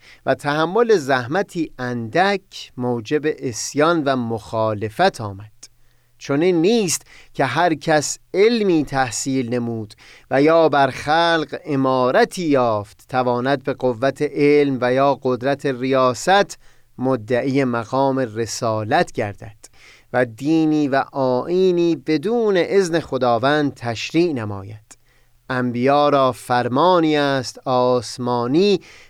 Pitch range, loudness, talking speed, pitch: 125-155 Hz, -19 LUFS, 100 wpm, 135 Hz